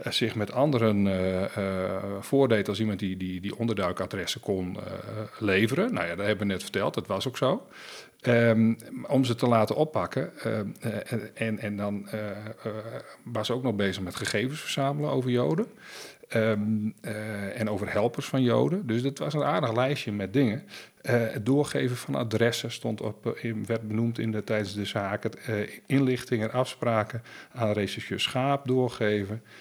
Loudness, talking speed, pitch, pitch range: -28 LUFS, 170 wpm, 110 Hz, 105-125 Hz